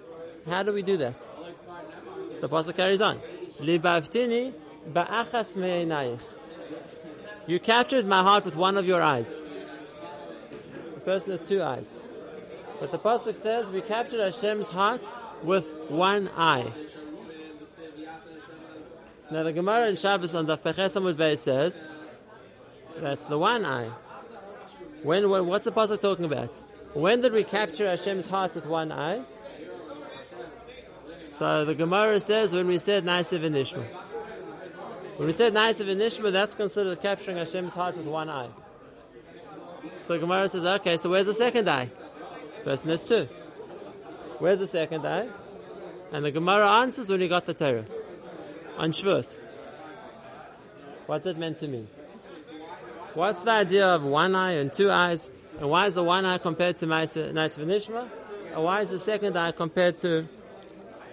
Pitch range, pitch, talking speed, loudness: 160-205 Hz, 180 Hz, 140 wpm, -26 LUFS